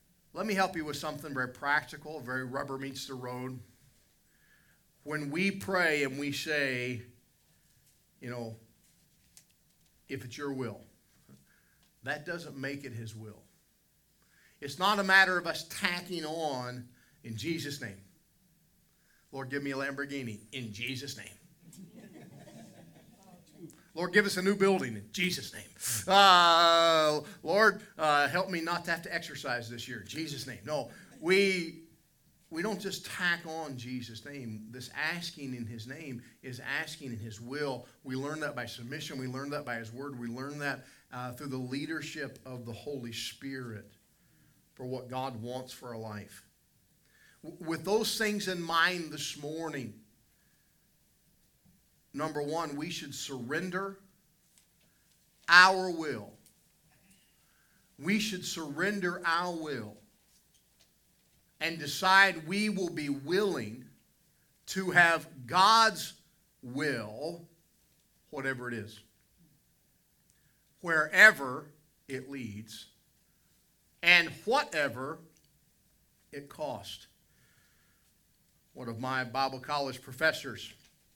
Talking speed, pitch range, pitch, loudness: 125 wpm, 125-170 Hz, 145 Hz, -30 LUFS